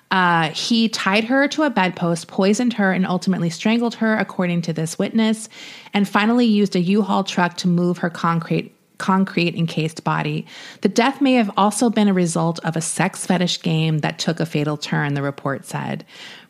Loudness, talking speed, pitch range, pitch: -19 LUFS, 185 wpm, 170-215 Hz, 185 Hz